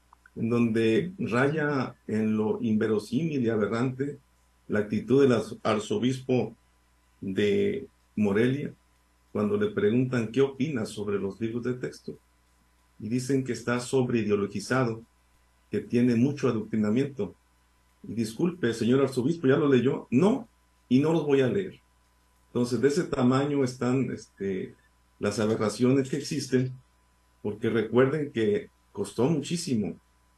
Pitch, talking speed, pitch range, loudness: 120 Hz, 125 wpm, 100-135 Hz, -27 LUFS